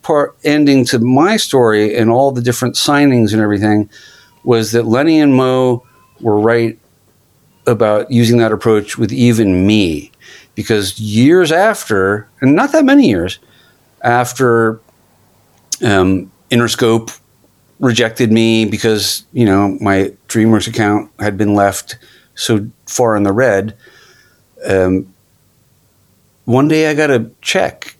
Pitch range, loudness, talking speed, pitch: 105-125 Hz, -13 LUFS, 125 wpm, 115 Hz